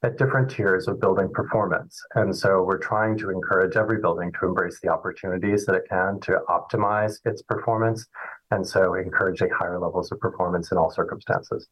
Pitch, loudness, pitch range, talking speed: 110 Hz, -24 LUFS, 105-120 Hz, 180 wpm